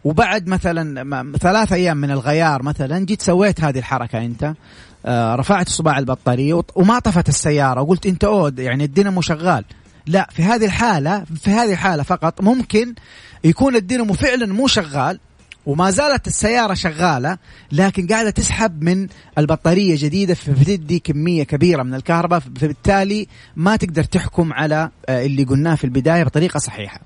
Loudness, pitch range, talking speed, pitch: -17 LUFS, 145-195 Hz, 140 wpm, 170 Hz